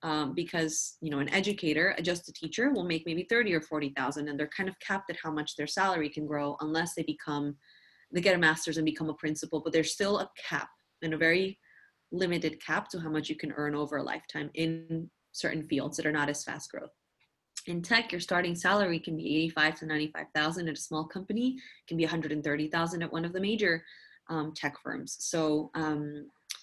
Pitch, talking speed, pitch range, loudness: 160 Hz, 225 wpm, 150-175 Hz, -31 LUFS